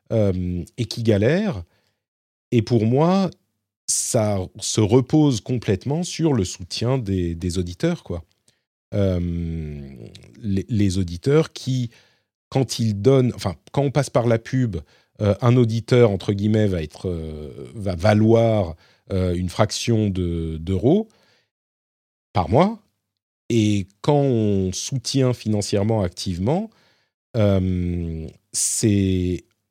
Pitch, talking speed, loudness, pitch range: 105 Hz, 115 wpm, -21 LUFS, 95-125 Hz